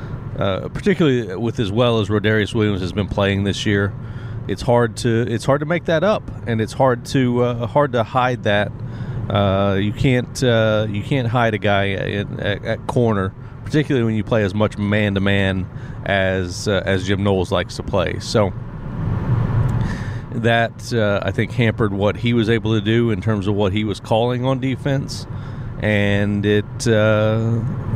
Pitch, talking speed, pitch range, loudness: 115 Hz, 180 wpm, 105-125 Hz, -19 LUFS